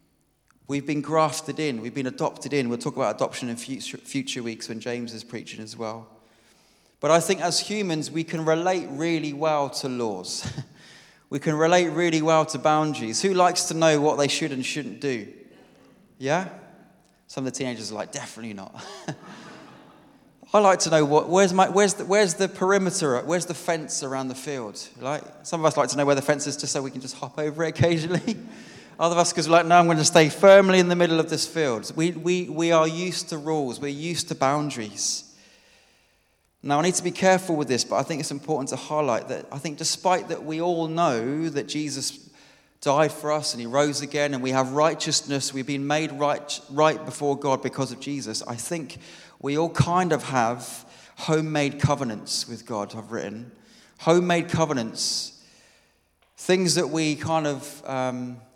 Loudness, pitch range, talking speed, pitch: -24 LUFS, 135-165 Hz, 200 wpm, 150 Hz